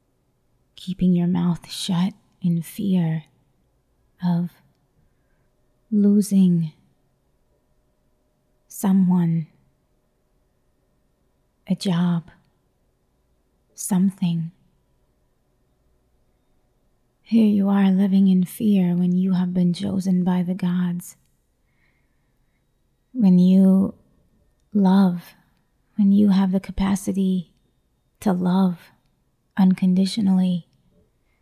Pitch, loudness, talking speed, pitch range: 185 Hz, -20 LUFS, 70 wpm, 175-195 Hz